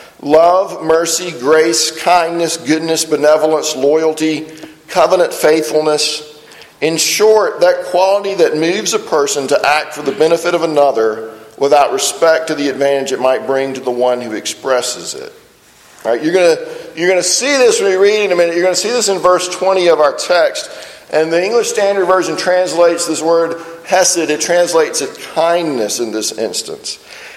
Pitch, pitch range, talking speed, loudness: 165 Hz, 150-185 Hz, 175 wpm, -13 LUFS